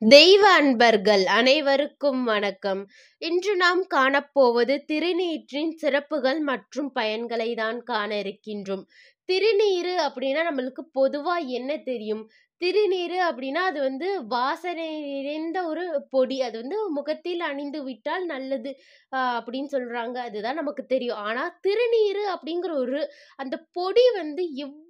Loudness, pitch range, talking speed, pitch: -24 LUFS, 255-345 Hz, 115 wpm, 285 Hz